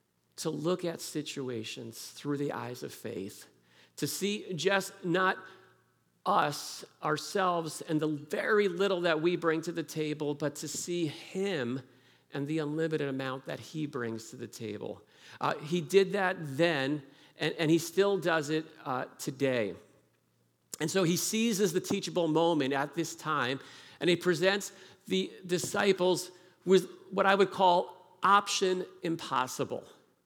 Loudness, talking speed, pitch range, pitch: -31 LUFS, 145 wpm, 145-185 Hz, 165 Hz